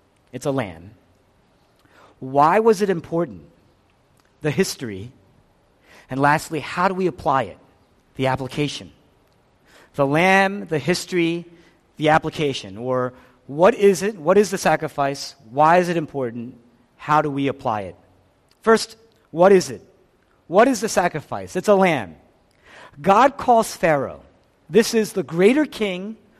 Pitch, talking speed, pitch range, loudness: 150 Hz, 135 wpm, 125-190 Hz, -20 LUFS